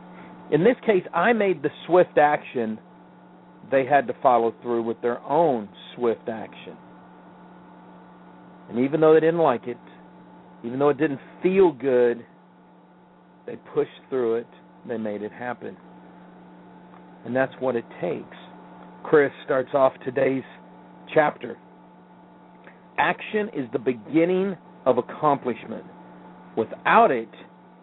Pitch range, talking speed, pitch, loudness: 120-165 Hz, 125 wpm, 130 Hz, -23 LUFS